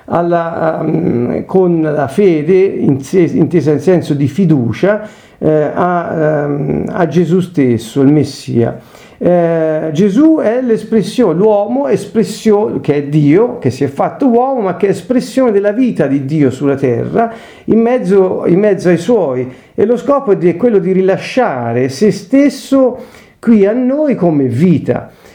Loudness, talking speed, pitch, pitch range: -12 LUFS, 160 wpm, 185 Hz, 150-220 Hz